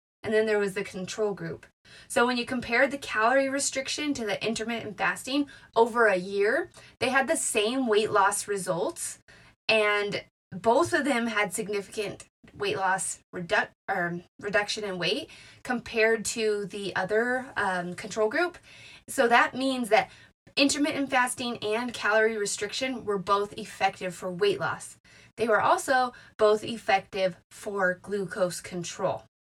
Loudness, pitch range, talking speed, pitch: -27 LUFS, 200-245 Hz, 145 wpm, 215 Hz